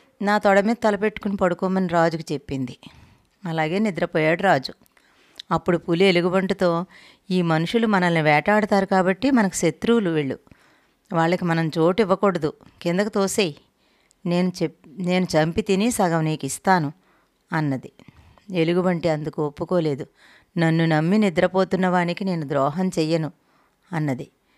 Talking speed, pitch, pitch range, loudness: 110 wpm, 175 Hz, 160-195 Hz, -22 LUFS